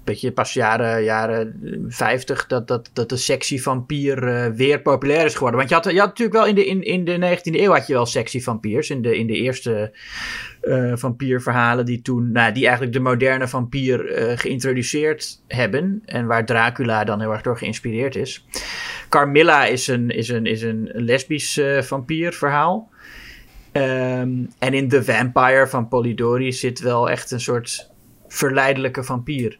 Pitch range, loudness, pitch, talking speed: 120-135 Hz, -19 LUFS, 125 Hz, 170 wpm